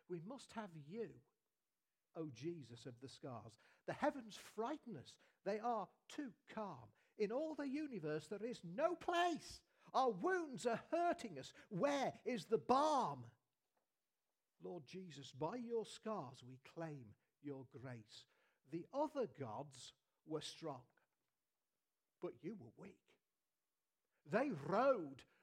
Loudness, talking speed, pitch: -45 LUFS, 130 wpm, 180 Hz